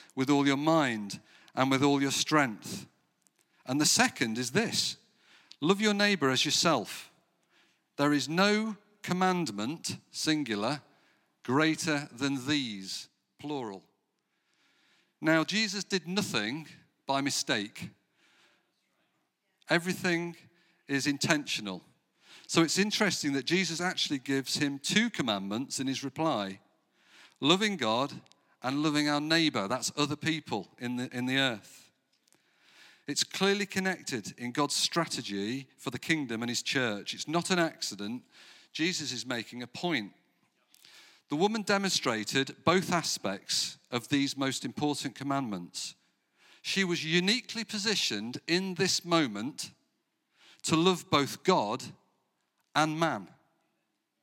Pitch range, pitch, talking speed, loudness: 135-180 Hz, 150 Hz, 120 wpm, -30 LUFS